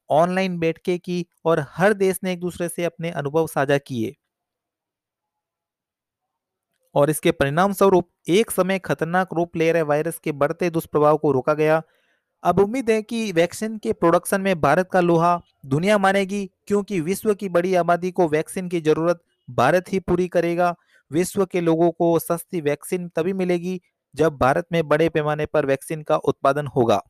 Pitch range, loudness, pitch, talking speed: 155-185 Hz, -21 LUFS, 170 Hz, 165 wpm